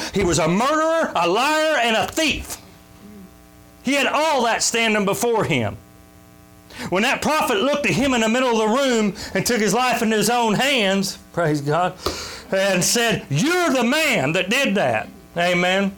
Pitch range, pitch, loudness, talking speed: 185-255 Hz, 220 Hz, -19 LUFS, 175 wpm